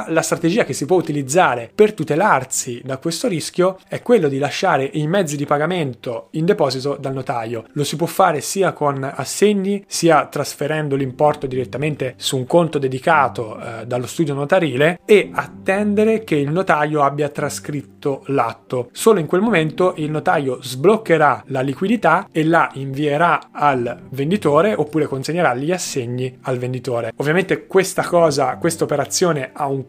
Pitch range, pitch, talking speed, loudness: 135-170 Hz, 150 Hz, 155 wpm, -18 LUFS